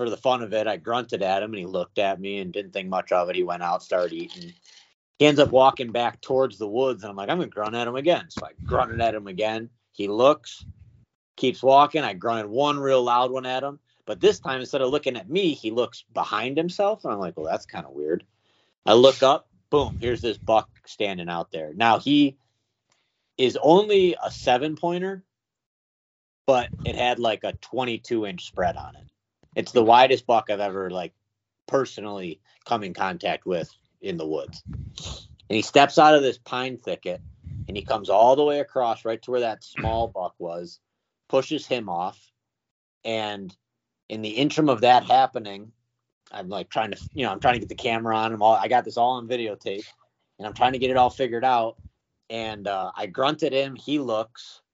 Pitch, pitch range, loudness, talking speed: 120 Hz, 105-135 Hz, -23 LUFS, 210 wpm